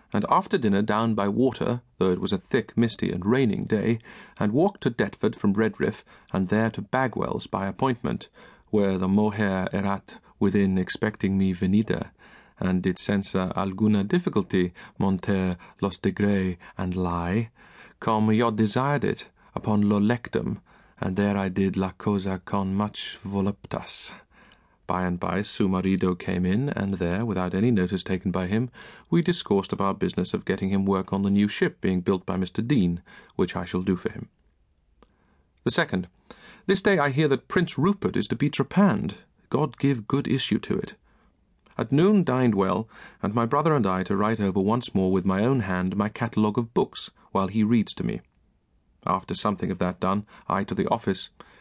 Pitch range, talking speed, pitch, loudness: 95-115 Hz, 180 wpm, 100 Hz, -25 LUFS